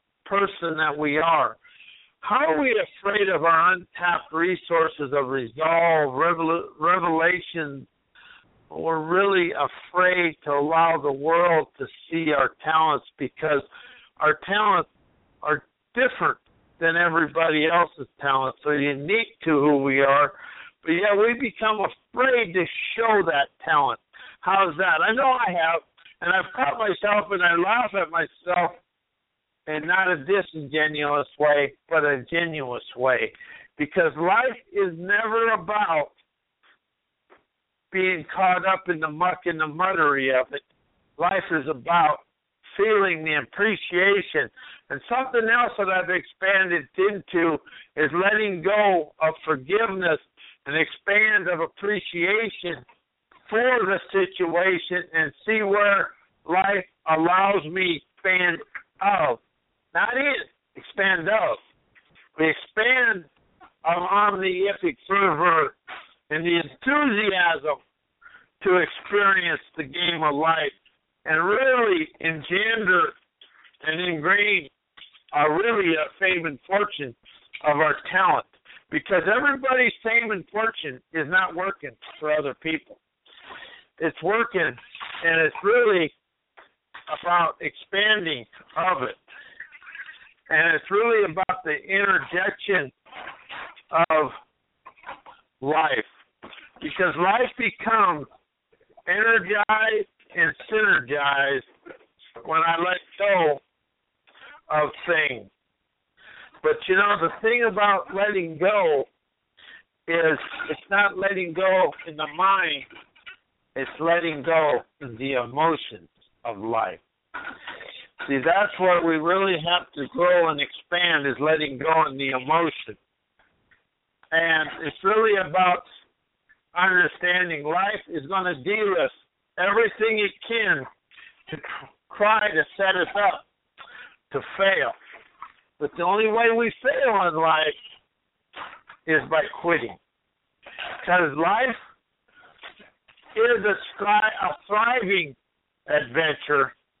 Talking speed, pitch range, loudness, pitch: 115 wpm, 160-205 Hz, -22 LUFS, 180 Hz